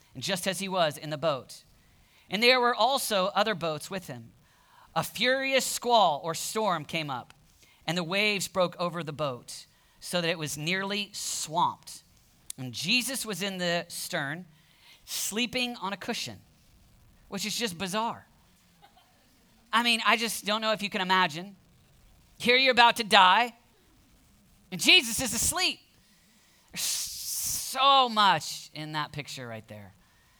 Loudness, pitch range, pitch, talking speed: -26 LUFS, 160-230 Hz, 190 Hz, 150 wpm